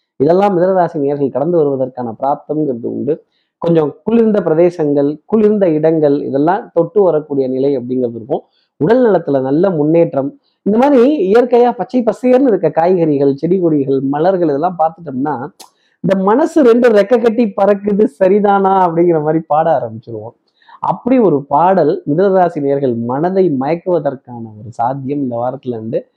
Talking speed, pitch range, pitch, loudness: 130 wpm, 140-200 Hz, 165 Hz, -13 LUFS